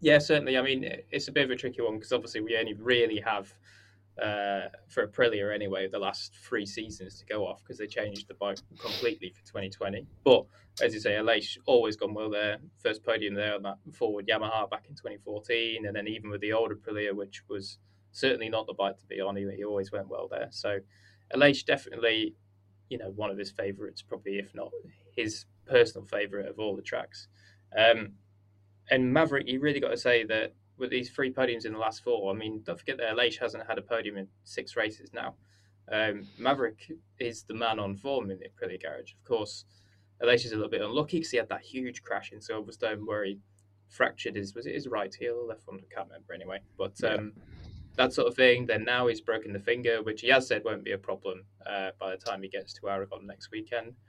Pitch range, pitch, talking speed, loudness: 100-115 Hz, 105 Hz, 220 wpm, -30 LUFS